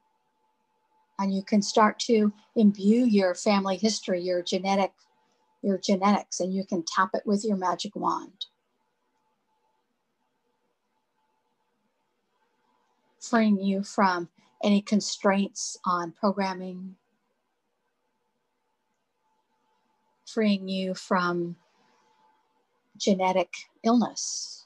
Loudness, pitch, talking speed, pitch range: -26 LUFS, 200 Hz, 85 wpm, 190-225 Hz